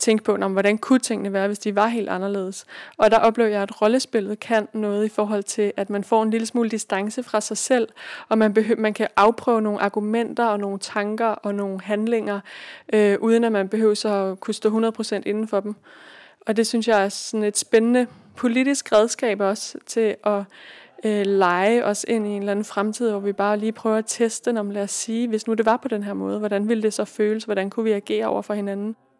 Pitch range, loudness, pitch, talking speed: 200-225 Hz, -22 LUFS, 215 Hz, 230 wpm